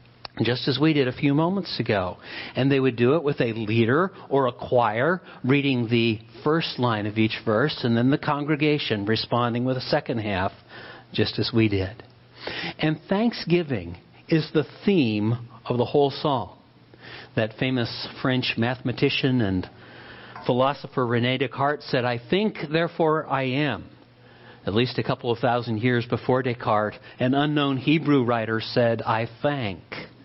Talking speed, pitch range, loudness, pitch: 155 wpm, 115-145 Hz, -24 LUFS, 125 Hz